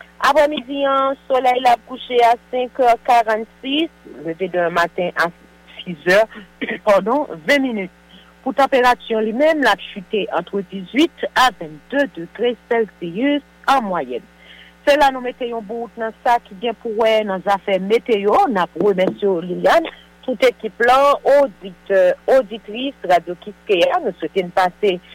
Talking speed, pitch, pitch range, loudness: 140 wpm, 225 Hz, 185-255 Hz, -18 LUFS